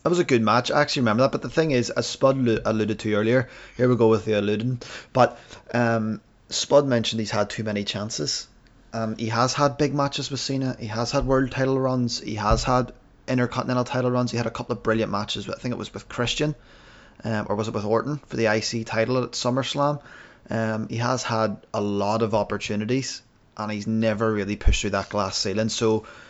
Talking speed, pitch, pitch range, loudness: 220 wpm, 115 Hz, 110-130 Hz, -24 LUFS